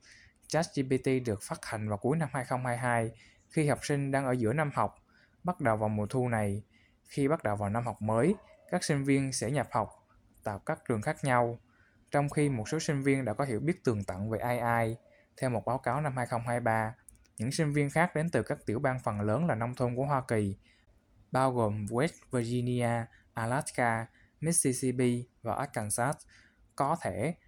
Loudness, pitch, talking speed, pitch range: -32 LUFS, 120 Hz, 190 wpm, 110-140 Hz